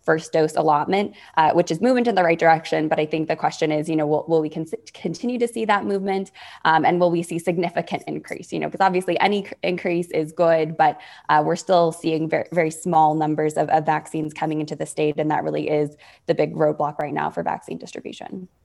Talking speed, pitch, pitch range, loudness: 225 wpm, 160 Hz, 155-180 Hz, -21 LUFS